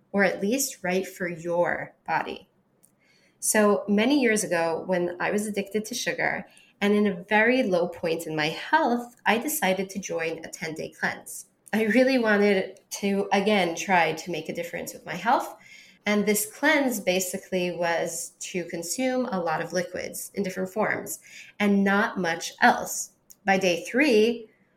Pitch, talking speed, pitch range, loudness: 195 Hz, 165 wpm, 175-215 Hz, -25 LUFS